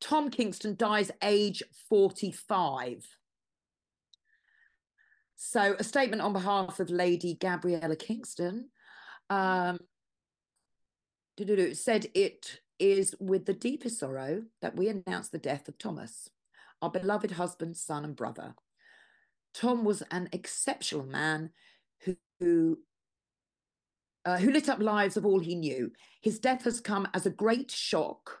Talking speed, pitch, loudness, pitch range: 125 wpm, 200 Hz, -31 LUFS, 180-245 Hz